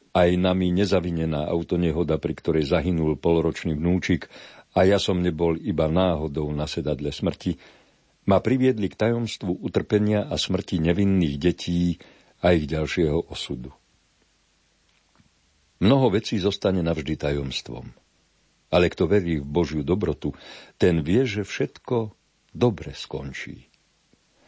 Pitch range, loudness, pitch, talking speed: 80-95 Hz, -24 LUFS, 85 Hz, 120 wpm